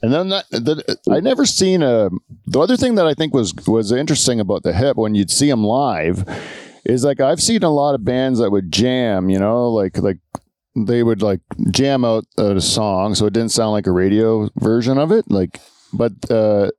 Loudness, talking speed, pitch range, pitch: -16 LUFS, 210 wpm, 105-140 Hz, 115 Hz